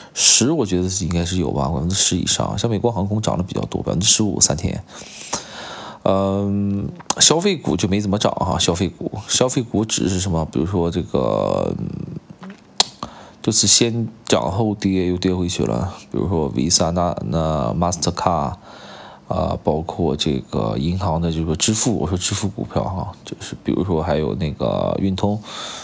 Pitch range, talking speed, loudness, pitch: 85-110 Hz, 275 characters per minute, -19 LUFS, 95 Hz